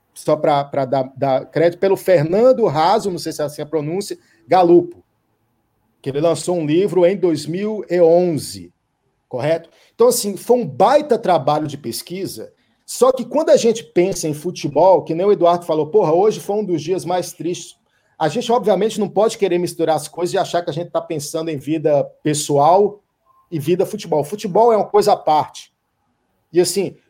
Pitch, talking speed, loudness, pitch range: 175 Hz, 185 wpm, -17 LUFS, 155-200 Hz